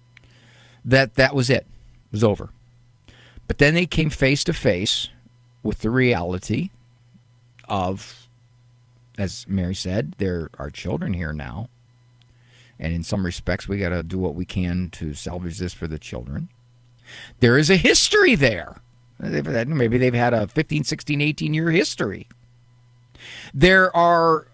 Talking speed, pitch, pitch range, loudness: 145 wpm, 120 Hz, 100-125 Hz, -21 LUFS